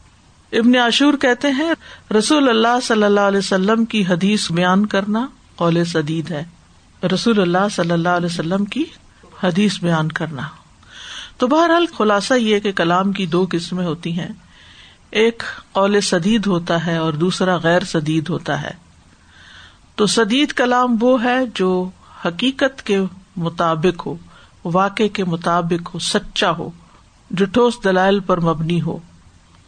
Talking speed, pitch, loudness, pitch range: 140 wpm, 190 Hz, -17 LUFS, 170-225 Hz